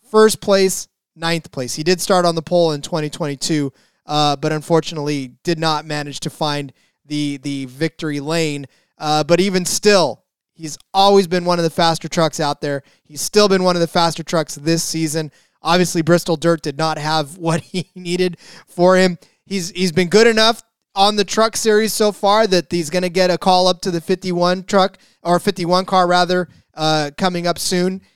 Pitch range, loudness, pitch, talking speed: 155-185 Hz, -17 LUFS, 170 Hz, 200 wpm